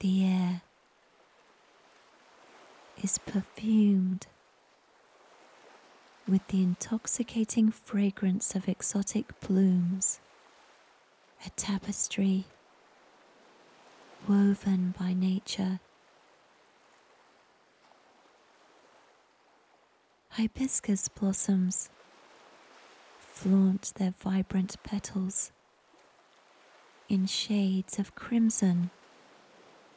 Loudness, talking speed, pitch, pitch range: -30 LUFS, 50 wpm, 195 Hz, 190-205 Hz